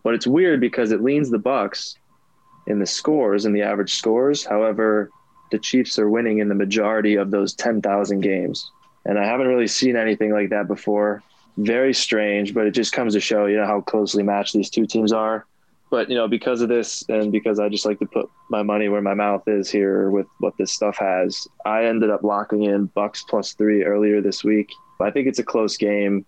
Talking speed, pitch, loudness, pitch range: 215 wpm, 105 Hz, -20 LUFS, 100-110 Hz